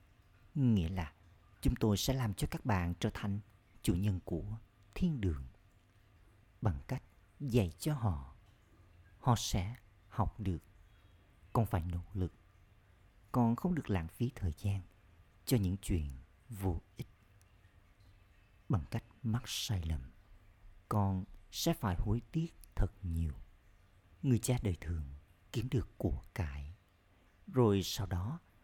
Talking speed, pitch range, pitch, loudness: 135 wpm, 90-110 Hz, 100 Hz, -37 LUFS